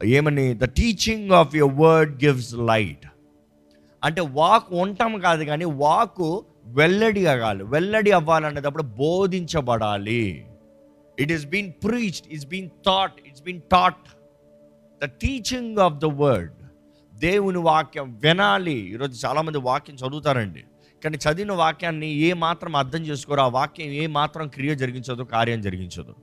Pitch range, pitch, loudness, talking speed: 125-175 Hz, 150 Hz, -22 LUFS, 130 wpm